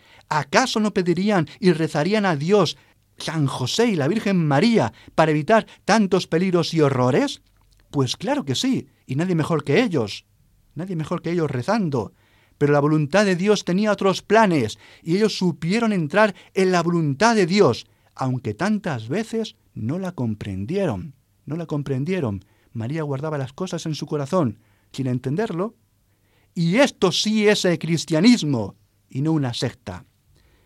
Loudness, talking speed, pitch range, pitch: -21 LUFS, 155 wpm, 125-190 Hz, 160 Hz